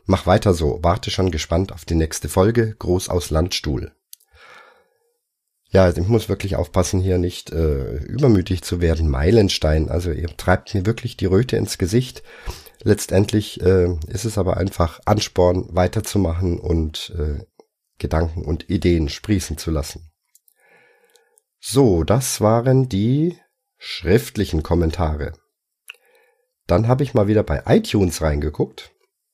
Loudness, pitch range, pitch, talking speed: -20 LUFS, 85-110 Hz, 95 Hz, 135 wpm